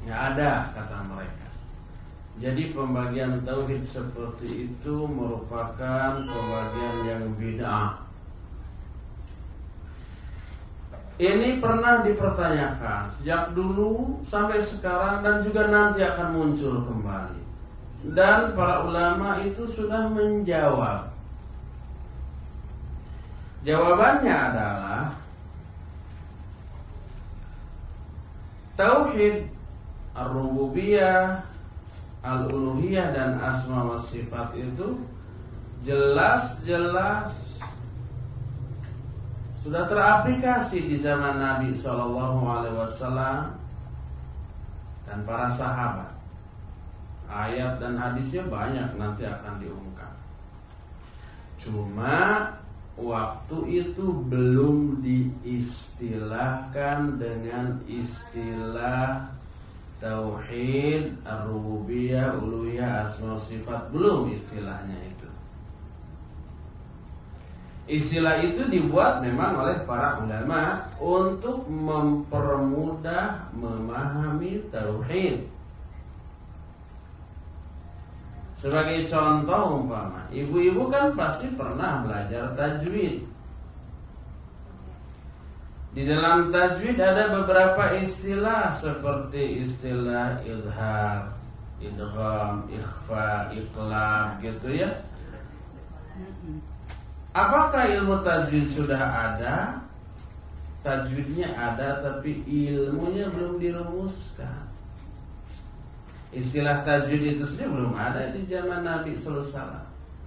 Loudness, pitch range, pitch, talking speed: -26 LUFS, 95-145 Hz, 120 Hz, 70 wpm